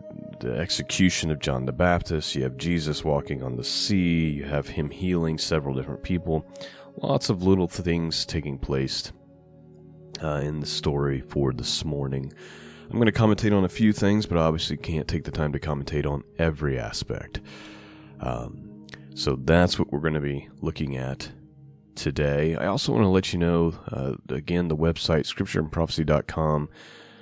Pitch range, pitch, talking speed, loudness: 70-90 Hz, 80 Hz, 170 wpm, -26 LUFS